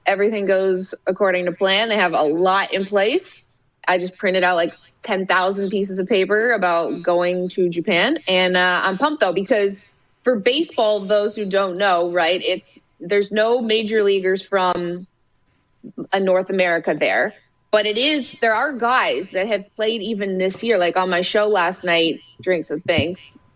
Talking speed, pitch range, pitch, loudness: 175 wpm, 180-215 Hz, 195 Hz, -19 LUFS